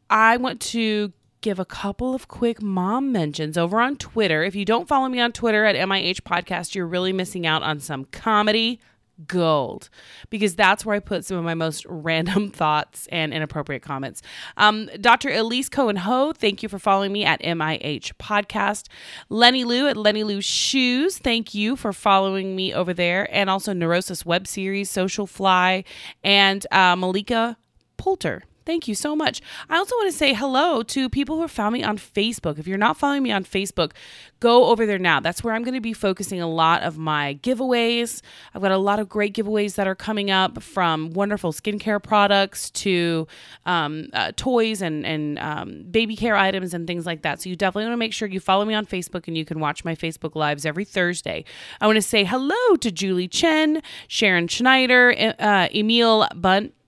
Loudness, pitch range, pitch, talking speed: -21 LUFS, 175-230 Hz, 200 Hz, 195 wpm